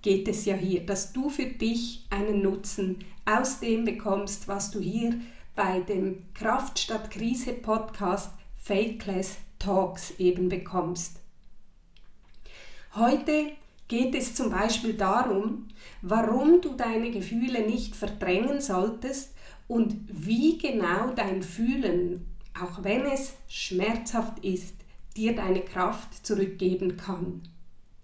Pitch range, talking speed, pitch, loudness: 190-235 Hz, 115 wpm, 210 Hz, -28 LUFS